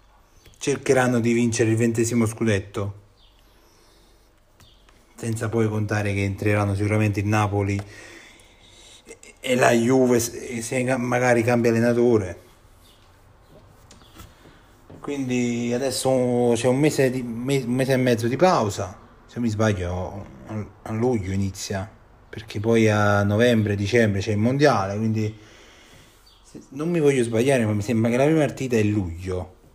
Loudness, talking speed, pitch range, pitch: -22 LUFS, 125 wpm, 100-120 Hz, 110 Hz